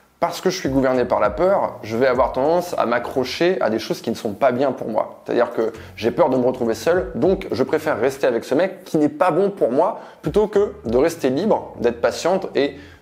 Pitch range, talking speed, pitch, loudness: 130-185 Hz, 245 wpm, 170 Hz, -20 LUFS